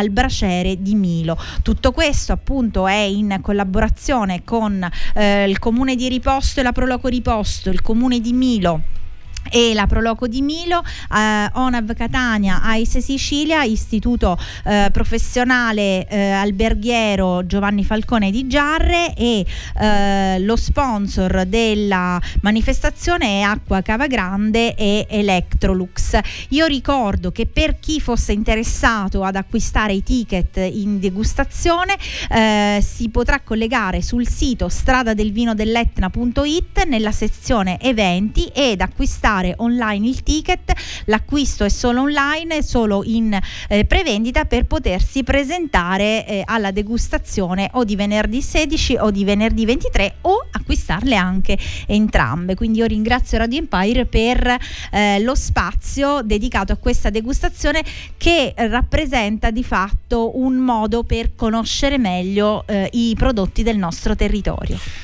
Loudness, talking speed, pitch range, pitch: -18 LUFS, 125 wpm, 200-255 Hz, 225 Hz